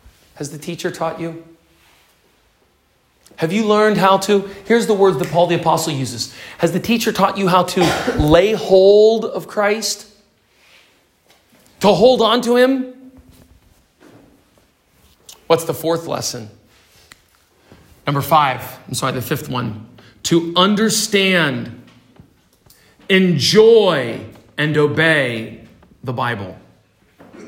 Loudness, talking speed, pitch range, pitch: -16 LUFS, 115 wpm, 130-205 Hz, 165 Hz